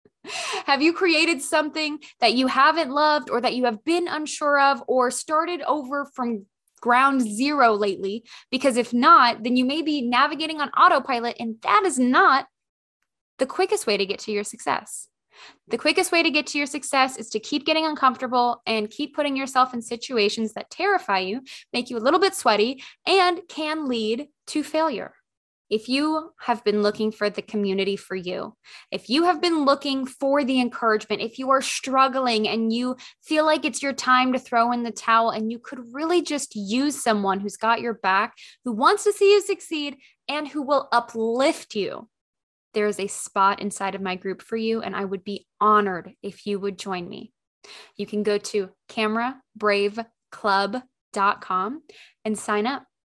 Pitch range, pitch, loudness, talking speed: 215-295 Hz, 250 Hz, -22 LUFS, 180 wpm